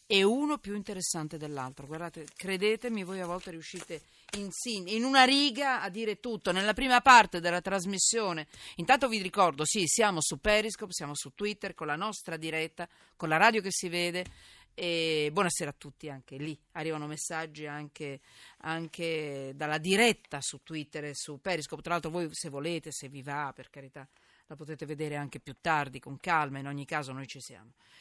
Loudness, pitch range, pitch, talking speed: -30 LUFS, 150-195 Hz, 165 Hz, 180 wpm